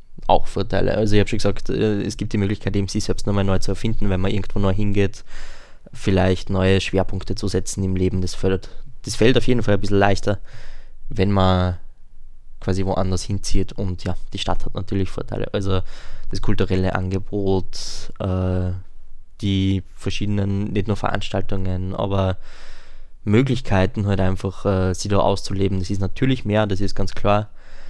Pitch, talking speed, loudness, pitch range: 100 Hz, 170 wpm, -22 LUFS, 95-105 Hz